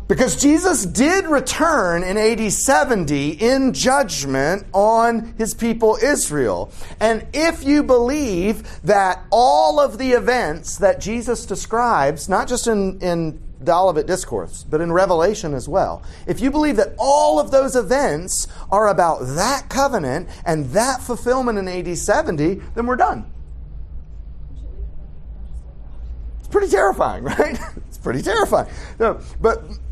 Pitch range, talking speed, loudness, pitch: 160-255 Hz, 135 wpm, -18 LUFS, 215 Hz